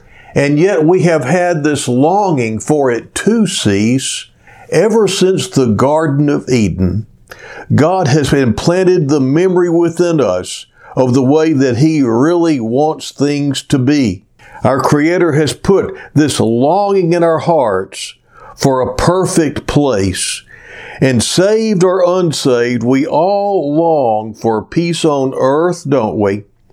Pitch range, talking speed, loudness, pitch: 125-175 Hz, 135 wpm, -12 LUFS, 150 Hz